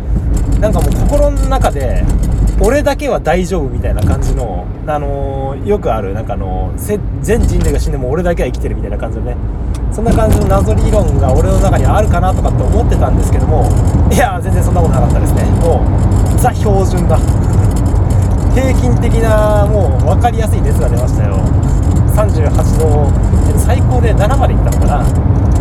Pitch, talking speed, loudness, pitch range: 100 Hz, 335 characters per minute, -13 LUFS, 95-105 Hz